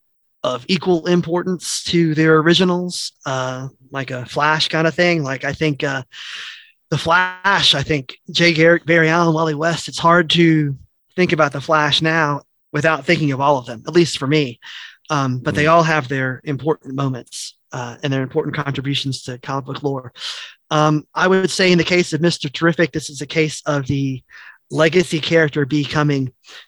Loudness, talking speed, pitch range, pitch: -17 LUFS, 180 wpm, 140-170 Hz, 155 Hz